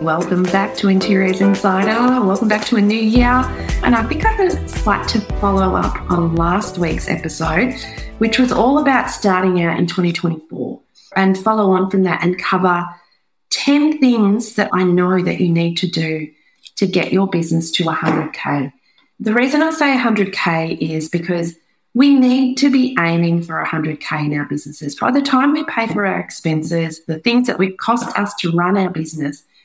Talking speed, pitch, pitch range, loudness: 180 wpm, 190 Hz, 170-230 Hz, -16 LUFS